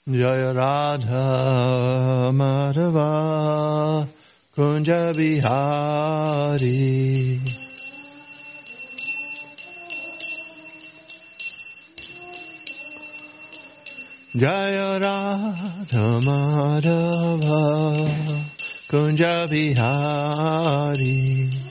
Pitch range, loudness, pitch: 135-195 Hz, -22 LUFS, 150 Hz